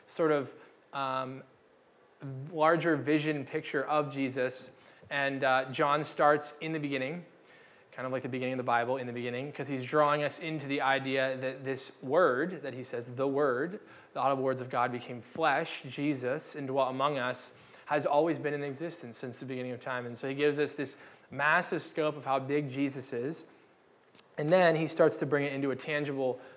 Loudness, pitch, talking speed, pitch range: -31 LUFS, 140 Hz, 195 wpm, 130-150 Hz